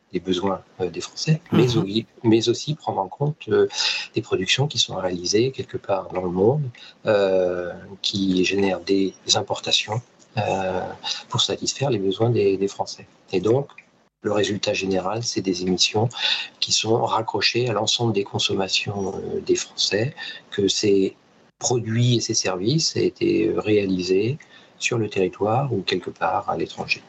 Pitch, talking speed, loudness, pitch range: 110 Hz, 145 wpm, -22 LUFS, 95-145 Hz